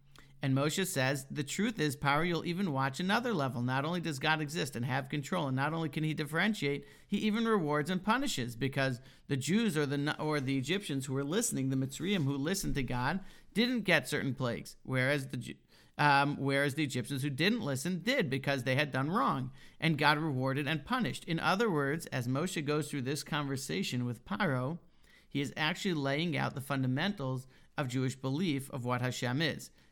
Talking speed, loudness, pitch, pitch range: 195 wpm, -33 LUFS, 145 Hz, 135-165 Hz